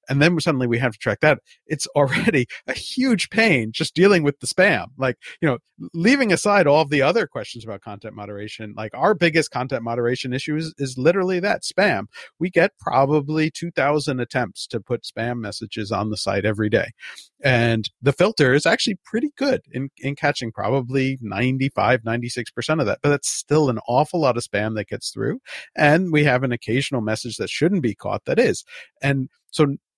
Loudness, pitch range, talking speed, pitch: -21 LUFS, 120-160 Hz, 190 wpm, 135 Hz